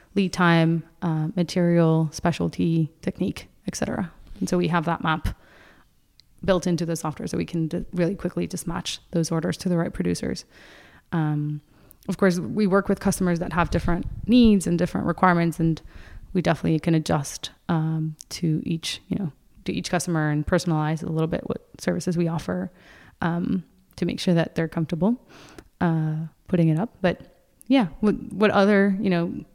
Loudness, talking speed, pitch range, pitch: -24 LUFS, 175 wpm, 160-185 Hz, 170 Hz